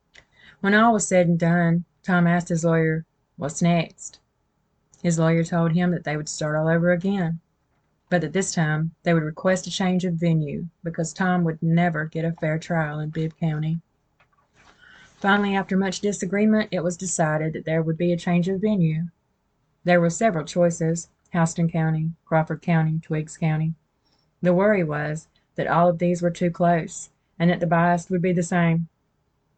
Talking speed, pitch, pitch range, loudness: 180 wpm, 170 Hz, 160-180 Hz, -23 LUFS